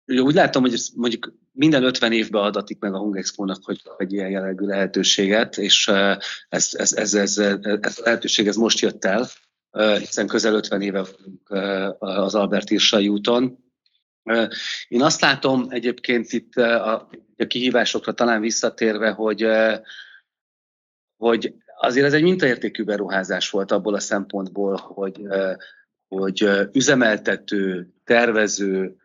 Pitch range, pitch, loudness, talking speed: 95-115 Hz, 105 Hz, -20 LUFS, 130 wpm